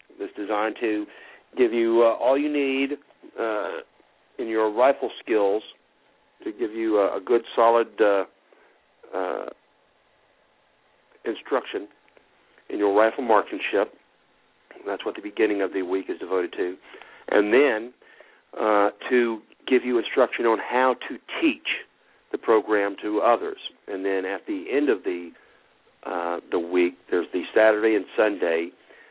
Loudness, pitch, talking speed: -24 LUFS, 120 Hz, 140 wpm